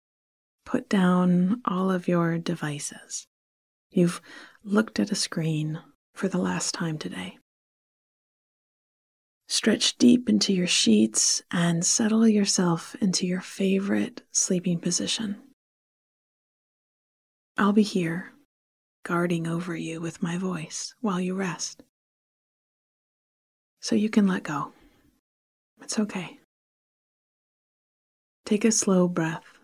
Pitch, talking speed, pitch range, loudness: 185 Hz, 105 wpm, 170-210 Hz, -25 LUFS